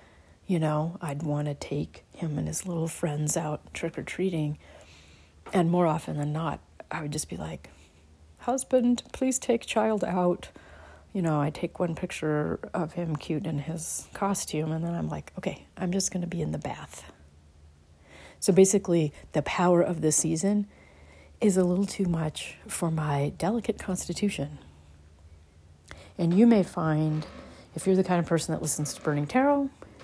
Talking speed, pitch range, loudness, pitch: 170 wpm, 145-185 Hz, -28 LUFS, 160 Hz